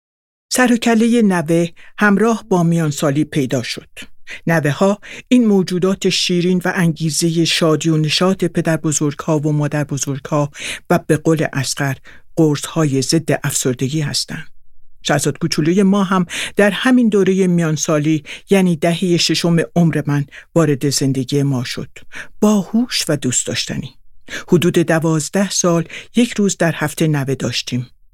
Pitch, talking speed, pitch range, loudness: 165 Hz, 140 wpm, 145-185 Hz, -16 LUFS